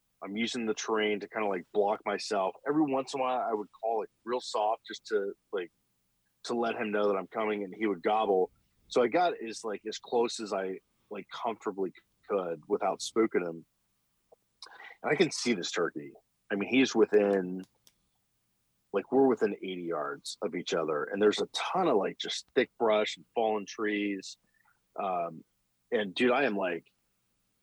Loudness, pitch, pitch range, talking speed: -31 LUFS, 105 Hz, 85-115 Hz, 190 wpm